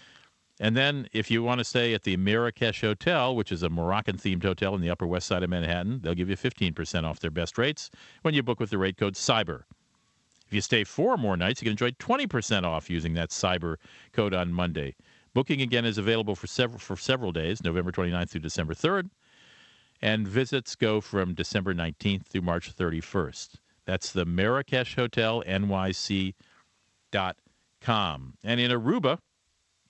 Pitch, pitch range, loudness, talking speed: 95 Hz, 90-115 Hz, -28 LUFS, 175 wpm